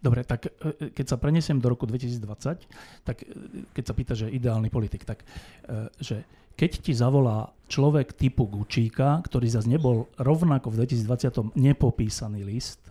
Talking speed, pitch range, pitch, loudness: 145 wpm, 115-135 Hz, 125 Hz, -26 LUFS